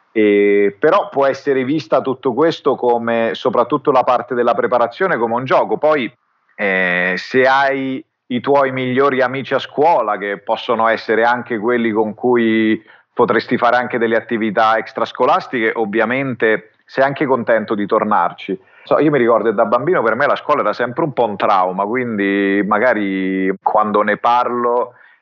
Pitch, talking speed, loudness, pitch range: 120 Hz, 155 wpm, -16 LUFS, 110-130 Hz